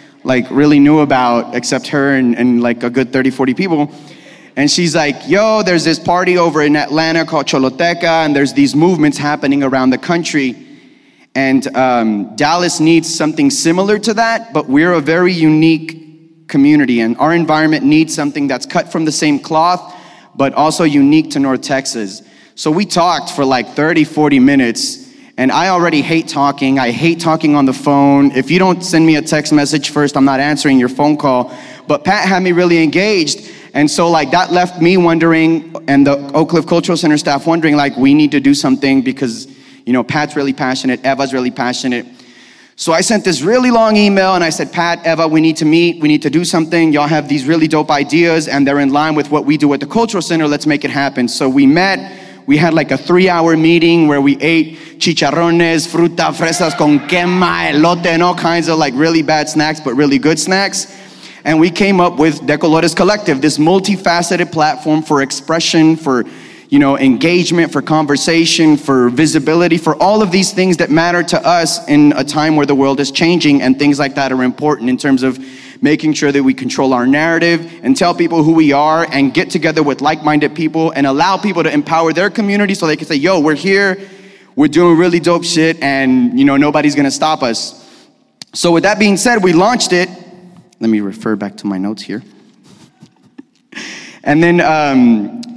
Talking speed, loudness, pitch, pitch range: 200 wpm, -12 LUFS, 155 Hz, 140-170 Hz